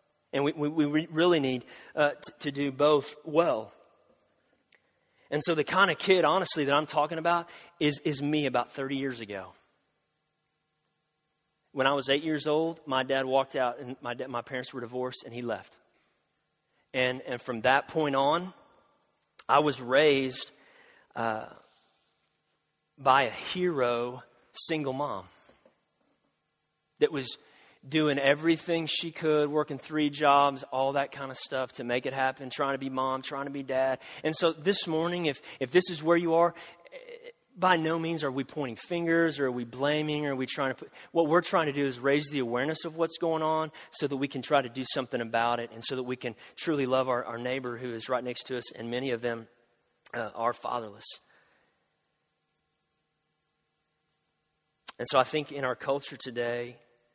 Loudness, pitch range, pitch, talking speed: -29 LUFS, 130-155 Hz, 140 Hz, 180 wpm